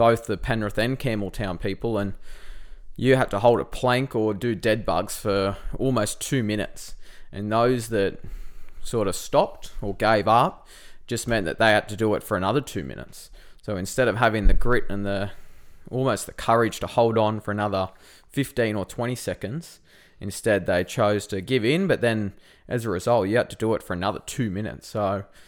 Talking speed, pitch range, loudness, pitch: 195 wpm, 100-120 Hz, -24 LUFS, 110 Hz